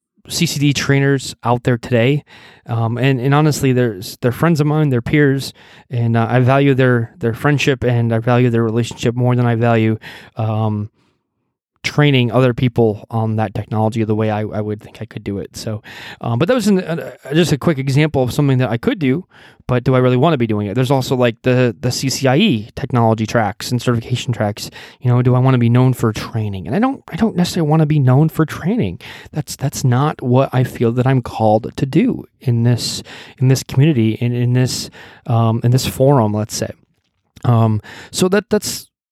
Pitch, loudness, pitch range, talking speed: 125 Hz, -16 LUFS, 115-140 Hz, 210 wpm